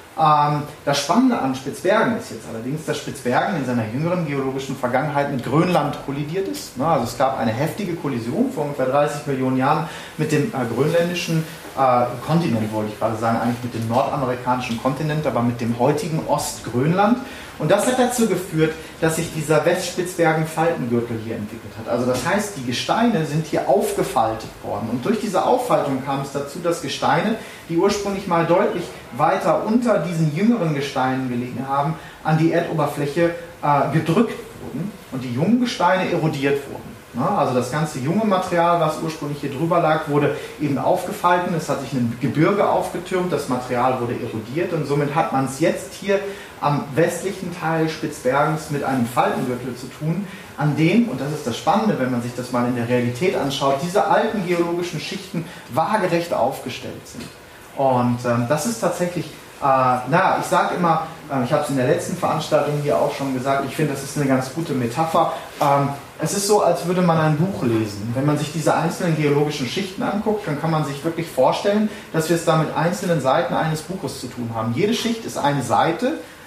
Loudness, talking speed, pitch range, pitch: -21 LUFS, 185 wpm, 130-170 Hz, 150 Hz